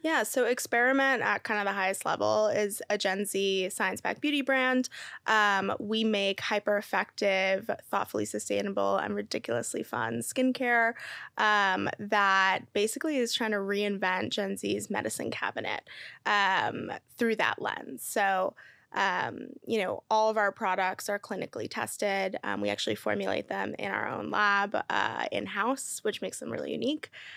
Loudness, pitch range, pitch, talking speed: -29 LUFS, 190-235 Hz, 205 Hz, 155 wpm